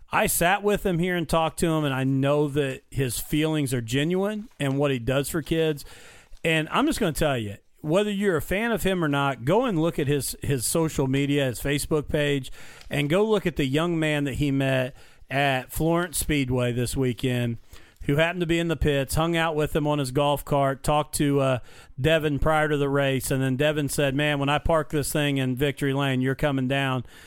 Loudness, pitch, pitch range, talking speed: -24 LUFS, 145 Hz, 135-160 Hz, 225 wpm